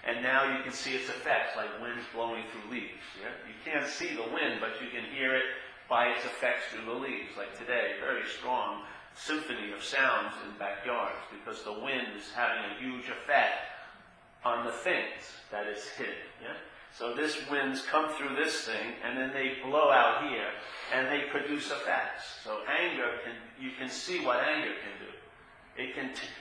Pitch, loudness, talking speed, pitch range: 130 Hz, -32 LUFS, 185 wpm, 120-145 Hz